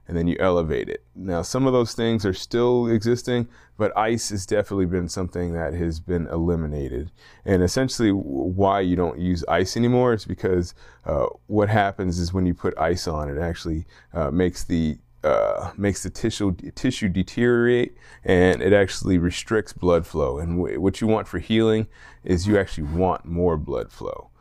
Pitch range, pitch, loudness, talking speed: 85-110 Hz, 95 Hz, -23 LUFS, 185 wpm